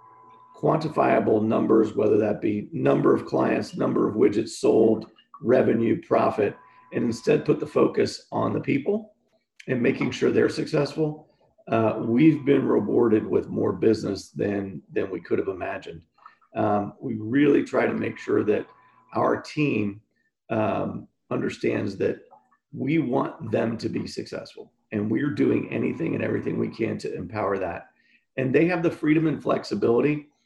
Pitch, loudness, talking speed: 150 Hz, -24 LUFS, 150 wpm